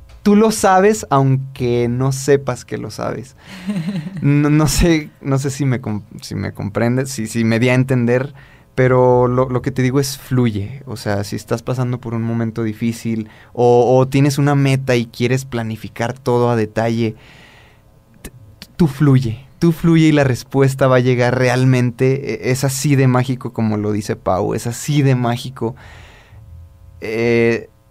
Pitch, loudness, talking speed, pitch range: 125 Hz, -16 LUFS, 170 wpm, 115-135 Hz